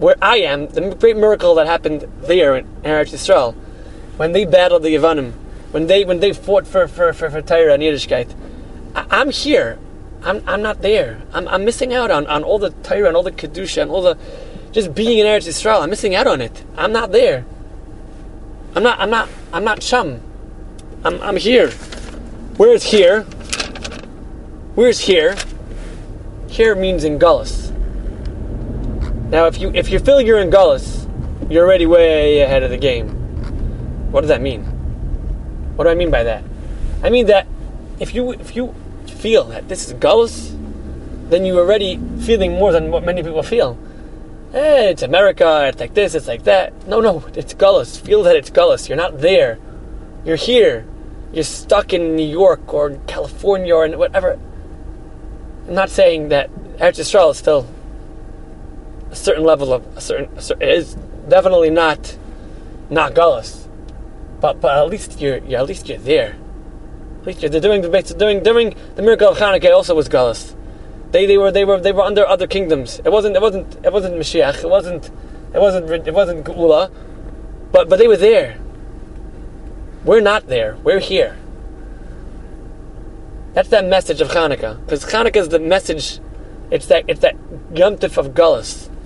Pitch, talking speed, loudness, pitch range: 190 Hz, 170 wpm, -15 LUFS, 155-245 Hz